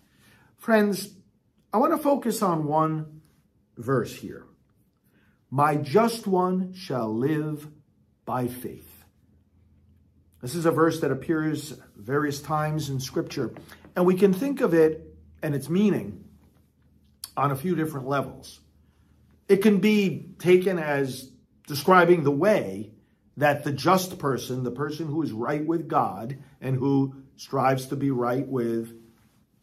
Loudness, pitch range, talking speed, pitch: -25 LUFS, 120-170 Hz, 135 wpm, 145 Hz